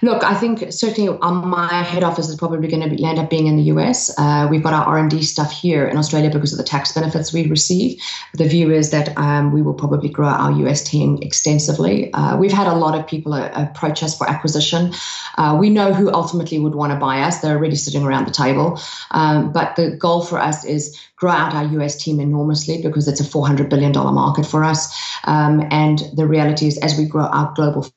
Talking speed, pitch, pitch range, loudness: 225 wpm, 155 Hz, 150-165 Hz, -17 LUFS